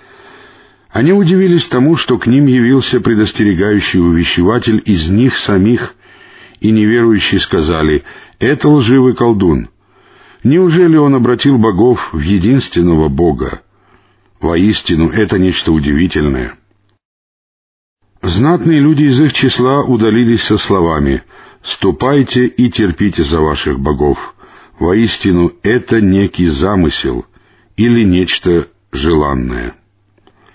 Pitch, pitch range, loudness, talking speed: 110 Hz, 90-125 Hz, -11 LUFS, 100 wpm